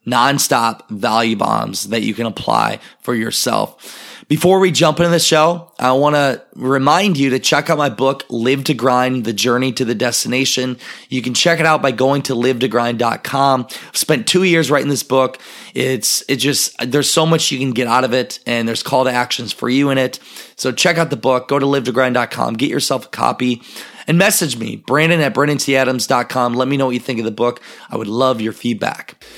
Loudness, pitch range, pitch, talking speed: -15 LUFS, 125-145 Hz, 130 Hz, 210 wpm